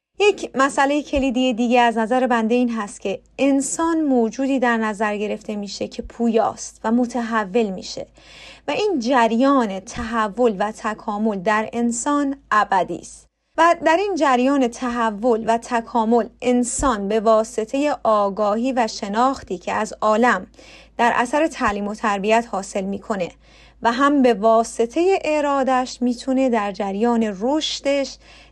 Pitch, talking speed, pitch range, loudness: 235 Hz, 135 wpm, 220-265 Hz, -20 LUFS